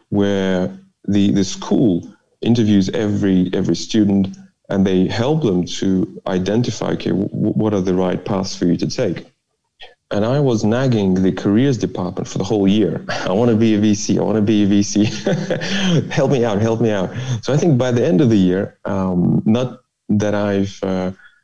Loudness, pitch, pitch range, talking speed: -17 LUFS, 105 Hz, 95-120 Hz, 190 wpm